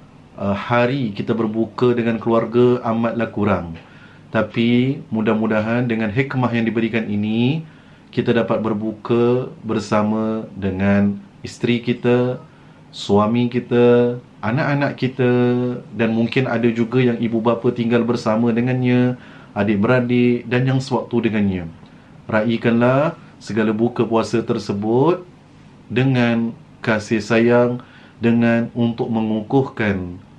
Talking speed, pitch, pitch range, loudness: 105 wpm, 120 Hz, 110-125 Hz, -19 LUFS